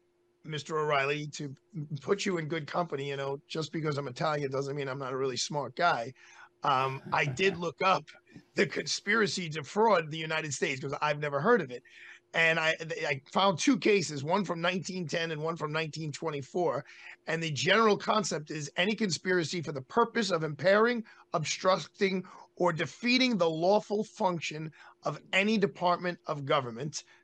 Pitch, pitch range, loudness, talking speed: 165 Hz, 150-190 Hz, -30 LUFS, 165 wpm